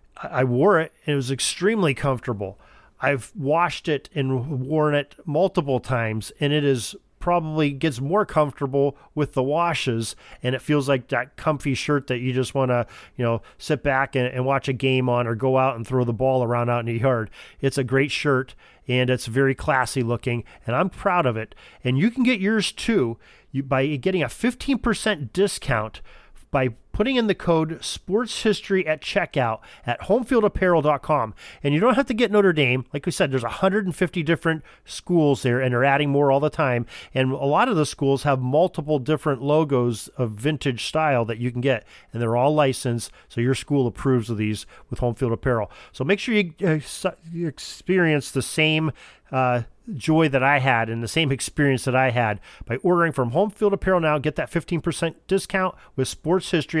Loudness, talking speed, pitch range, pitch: -23 LUFS, 195 wpm, 125-165 Hz, 140 Hz